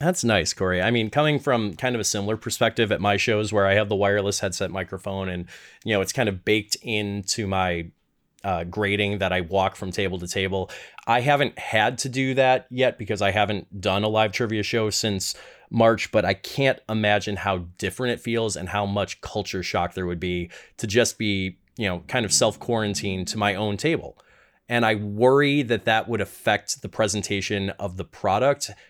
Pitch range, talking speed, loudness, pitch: 95-115 Hz, 205 wpm, -23 LUFS, 105 Hz